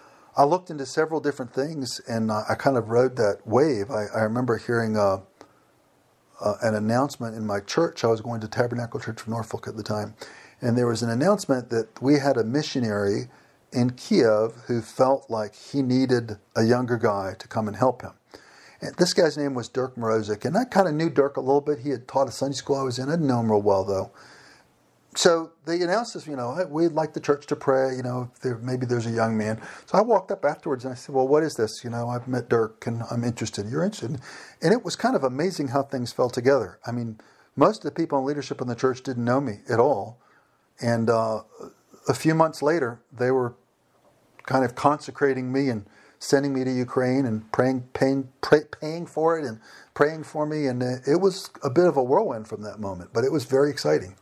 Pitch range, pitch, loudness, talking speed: 115-140 Hz, 130 Hz, -25 LUFS, 225 wpm